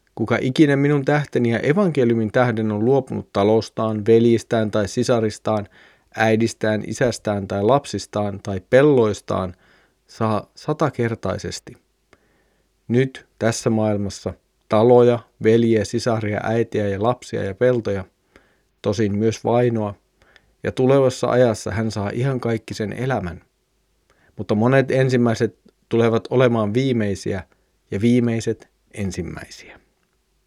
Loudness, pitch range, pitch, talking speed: -20 LUFS, 105-120 Hz, 110 Hz, 105 wpm